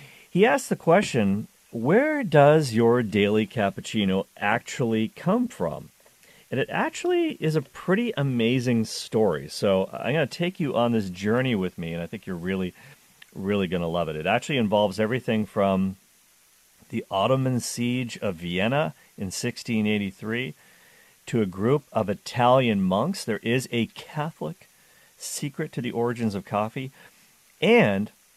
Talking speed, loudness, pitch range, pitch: 145 wpm, -25 LUFS, 100-145 Hz, 115 Hz